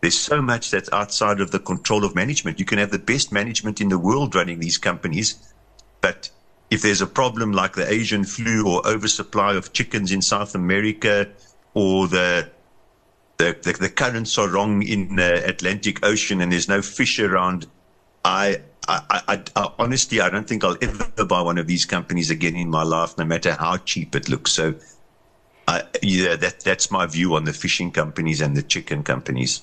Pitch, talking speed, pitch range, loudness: 100 Hz, 190 wpm, 90-105 Hz, -21 LUFS